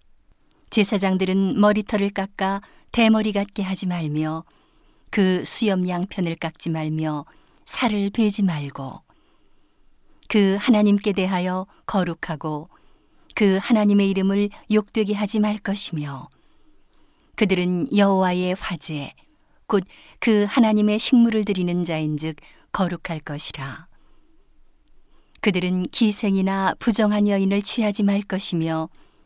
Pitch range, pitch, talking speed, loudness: 175-210 Hz, 195 Hz, 235 characters per minute, -22 LUFS